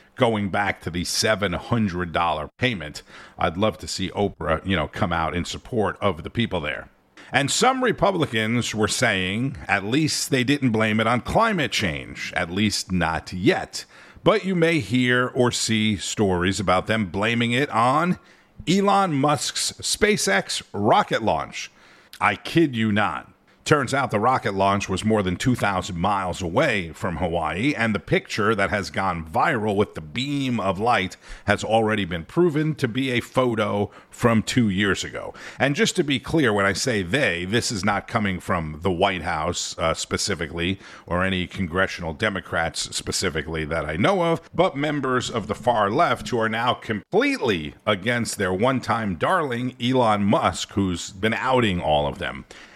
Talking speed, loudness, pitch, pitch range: 170 wpm, -22 LUFS, 105 Hz, 95-125 Hz